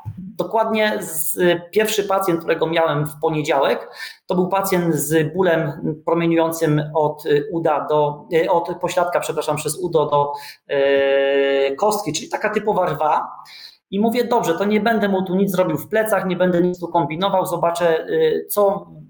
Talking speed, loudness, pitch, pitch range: 155 wpm, -19 LUFS, 175 Hz, 155-195 Hz